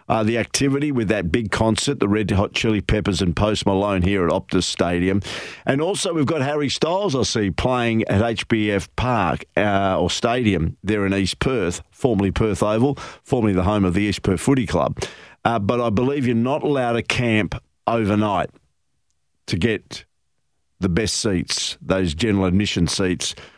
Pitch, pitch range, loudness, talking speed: 105 Hz, 95-115 Hz, -20 LUFS, 175 wpm